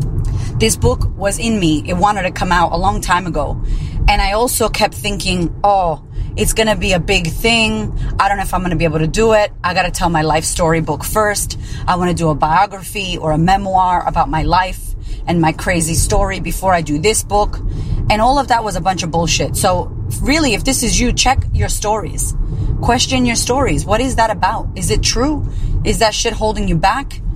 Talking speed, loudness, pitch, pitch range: 225 wpm, -15 LUFS, 165 Hz, 125-195 Hz